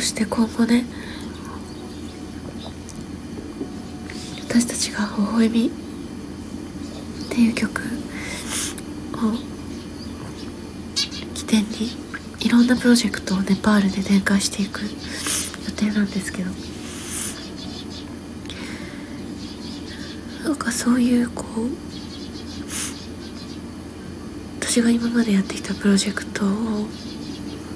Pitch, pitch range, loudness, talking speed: 220 Hz, 200-240 Hz, -23 LUFS, 175 characters per minute